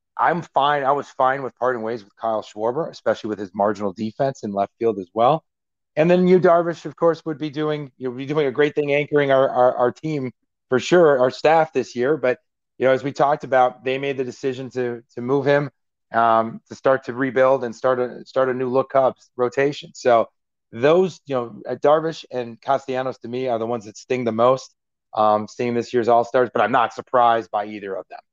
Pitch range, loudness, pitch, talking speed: 115-140 Hz, -21 LUFS, 130 Hz, 225 wpm